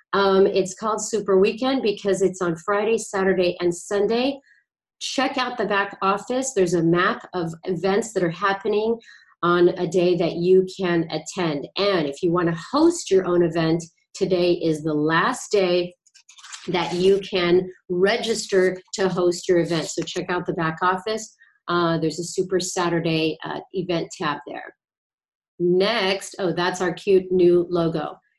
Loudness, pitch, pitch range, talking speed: -22 LUFS, 185 Hz, 175-200 Hz, 160 wpm